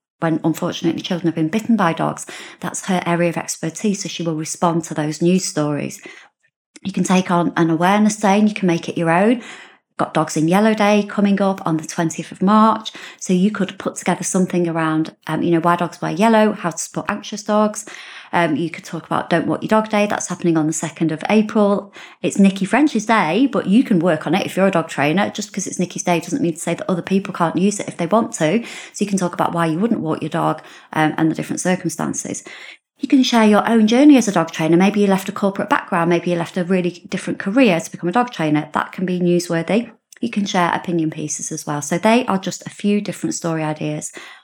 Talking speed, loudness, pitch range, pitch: 245 wpm, -18 LUFS, 165-205 Hz, 180 Hz